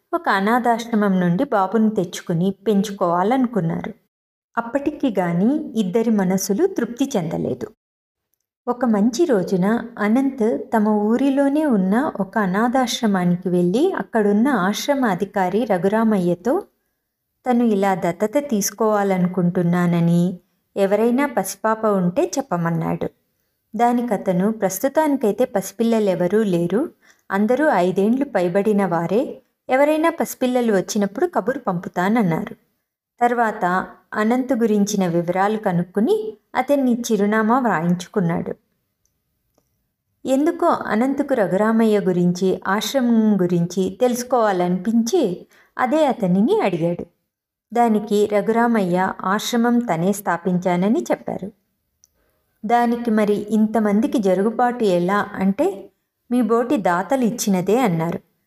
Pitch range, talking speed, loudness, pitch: 190-240 Hz, 85 wpm, -19 LUFS, 215 Hz